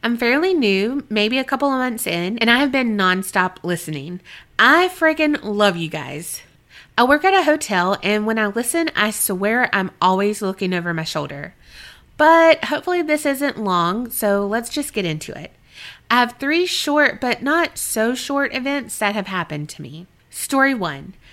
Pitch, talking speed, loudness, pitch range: 225 Hz, 180 wpm, -18 LUFS, 185-280 Hz